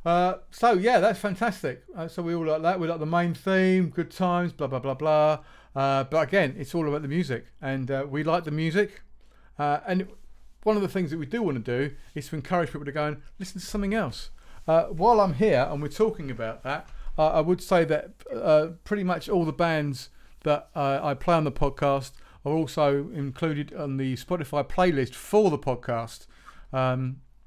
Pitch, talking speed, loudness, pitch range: 155 Hz, 210 wpm, -26 LUFS, 140-180 Hz